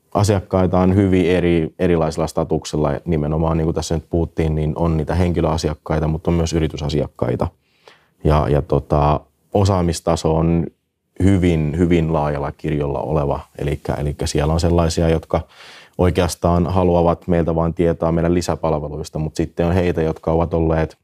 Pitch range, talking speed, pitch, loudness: 80-85 Hz, 140 wpm, 80 Hz, -19 LUFS